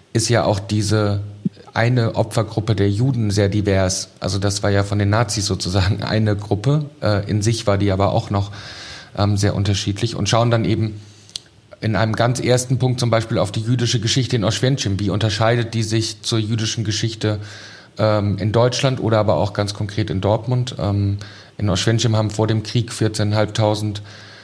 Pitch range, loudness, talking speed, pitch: 100-115 Hz, -19 LUFS, 170 wpm, 110 Hz